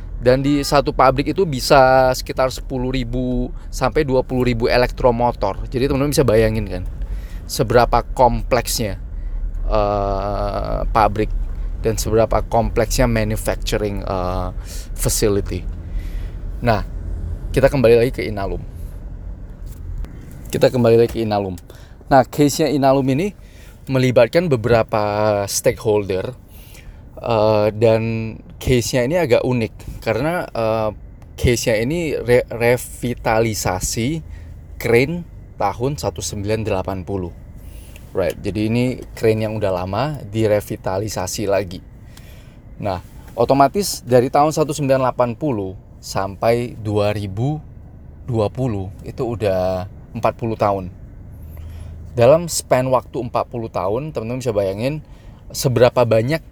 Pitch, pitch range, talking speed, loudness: 110 Hz, 95-125 Hz, 95 wpm, -19 LUFS